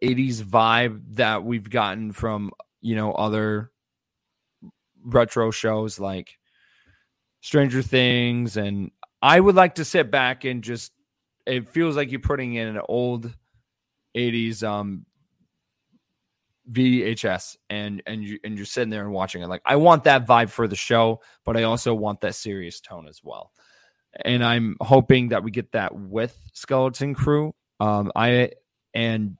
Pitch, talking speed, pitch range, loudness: 115 Hz, 150 wpm, 105-125 Hz, -22 LUFS